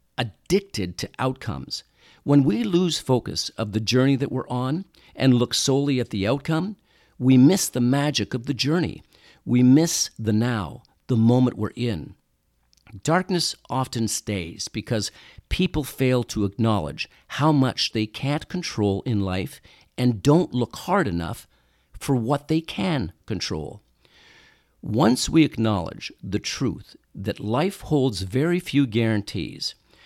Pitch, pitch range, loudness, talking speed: 125 Hz, 105-145 Hz, -23 LUFS, 140 wpm